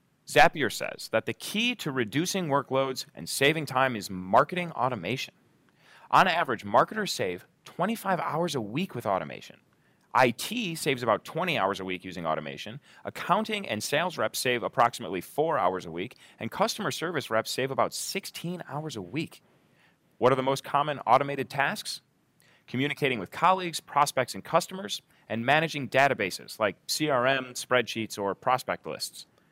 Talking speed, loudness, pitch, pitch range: 150 wpm, -28 LUFS, 140 Hz, 115-165 Hz